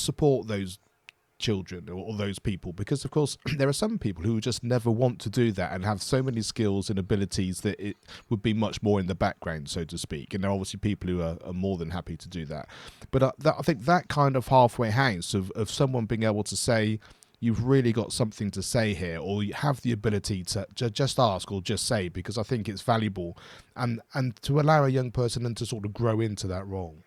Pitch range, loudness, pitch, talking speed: 95-125 Hz, -28 LUFS, 110 Hz, 240 wpm